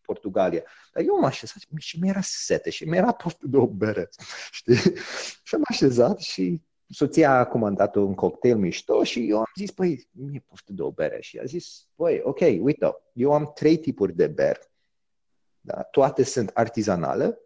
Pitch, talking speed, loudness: 170 Hz, 175 wpm, -24 LUFS